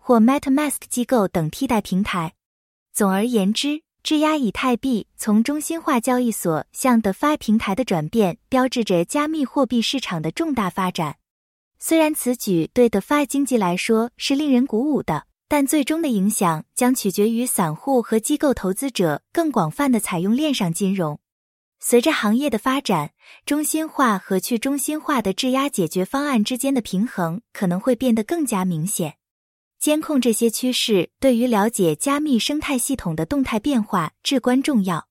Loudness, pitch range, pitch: -20 LUFS, 195-275 Hz, 240 Hz